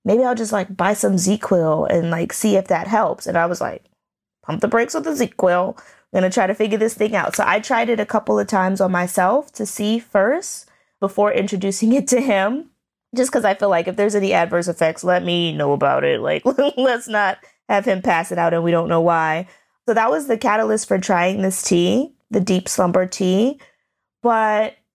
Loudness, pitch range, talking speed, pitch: -19 LUFS, 180-230 Hz, 220 wpm, 200 Hz